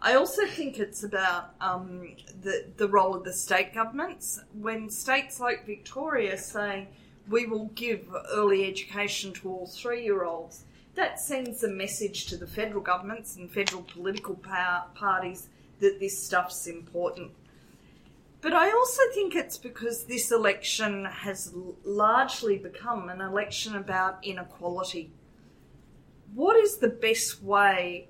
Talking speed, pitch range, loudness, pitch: 140 wpm, 185-230 Hz, -28 LUFS, 200 Hz